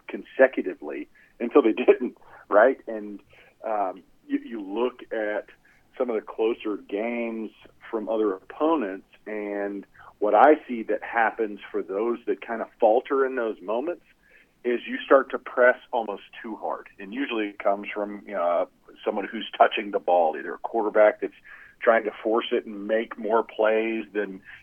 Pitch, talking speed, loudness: 115 Hz, 160 wpm, -25 LUFS